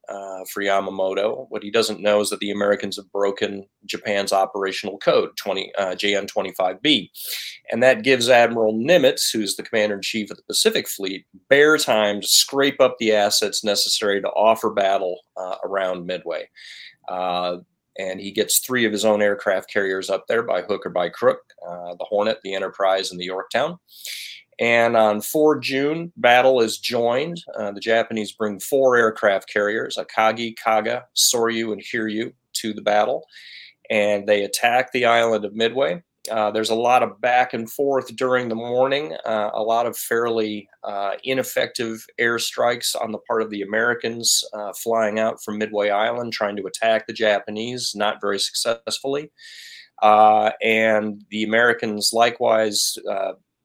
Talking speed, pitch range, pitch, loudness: 165 wpm, 100-120 Hz, 110 Hz, -20 LUFS